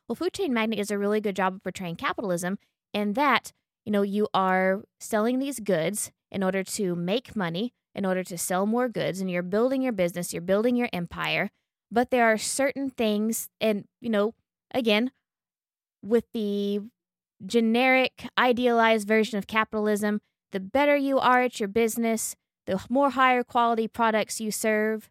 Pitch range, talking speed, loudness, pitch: 195-240 Hz, 170 wpm, -26 LUFS, 215 Hz